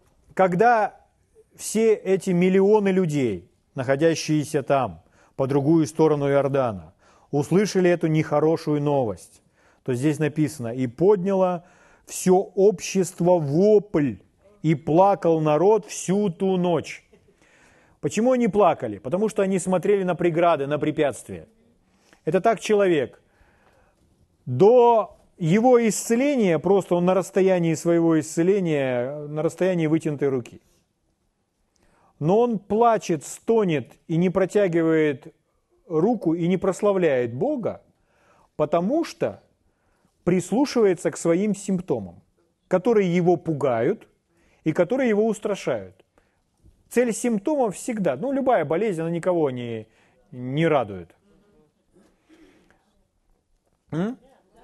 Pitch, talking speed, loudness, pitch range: 175 Hz, 100 wpm, -22 LUFS, 150-200 Hz